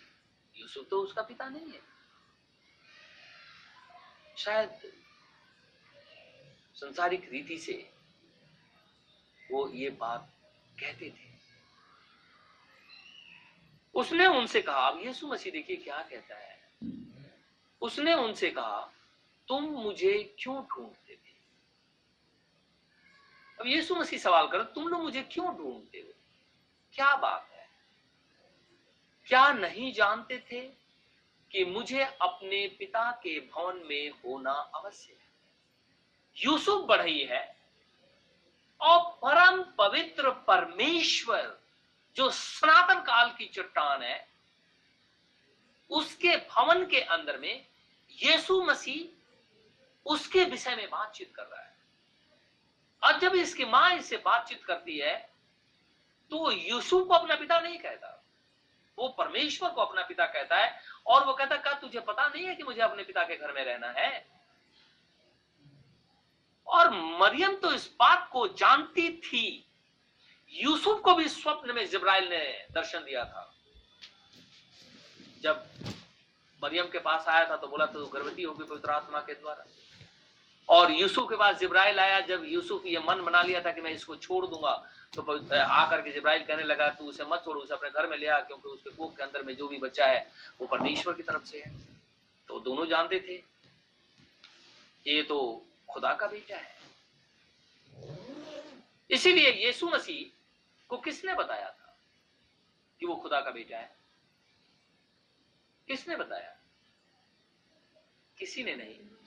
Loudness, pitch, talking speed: -28 LUFS, 270 Hz, 130 wpm